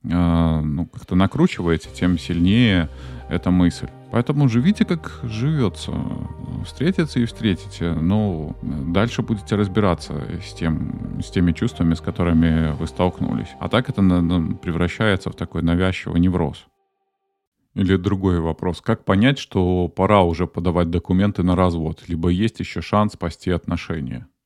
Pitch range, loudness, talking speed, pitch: 85-110 Hz, -21 LUFS, 130 wpm, 90 Hz